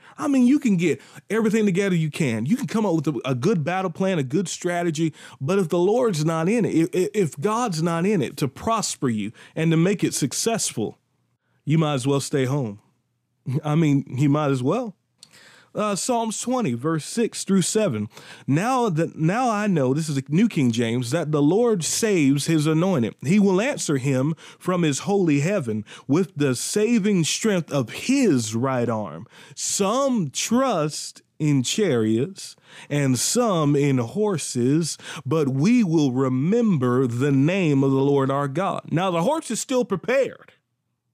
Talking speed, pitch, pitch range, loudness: 175 wpm, 165 Hz, 140-205 Hz, -22 LUFS